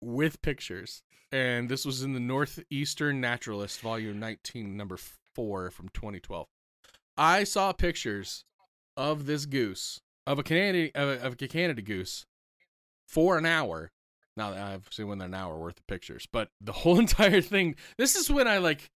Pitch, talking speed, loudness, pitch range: 135 Hz, 165 wpm, -29 LUFS, 105-165 Hz